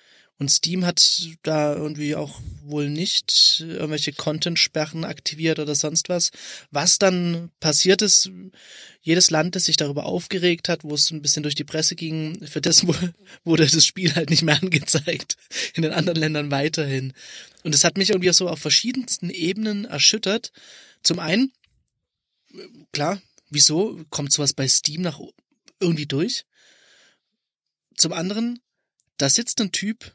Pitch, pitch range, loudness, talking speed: 165 Hz, 150-185 Hz, -20 LUFS, 150 wpm